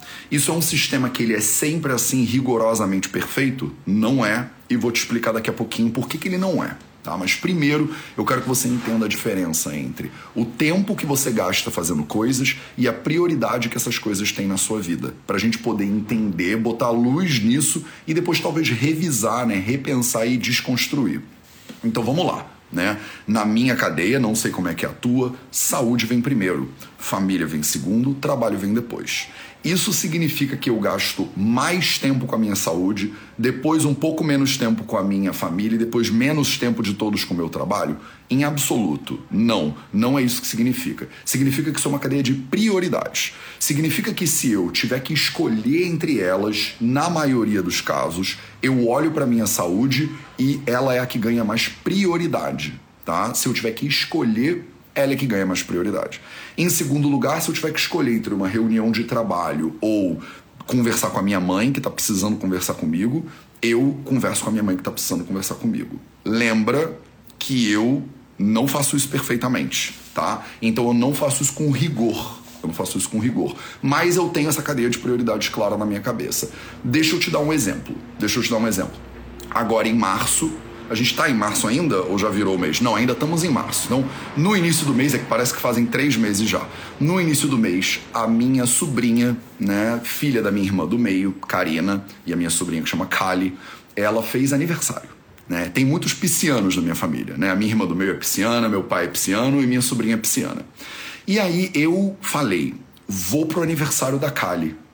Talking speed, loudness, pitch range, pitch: 200 wpm, -21 LUFS, 110-150 Hz, 125 Hz